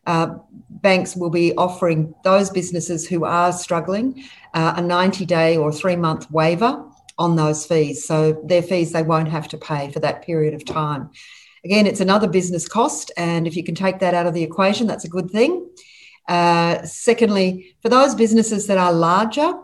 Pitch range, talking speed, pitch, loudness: 165-200 Hz, 185 wpm, 175 Hz, -19 LUFS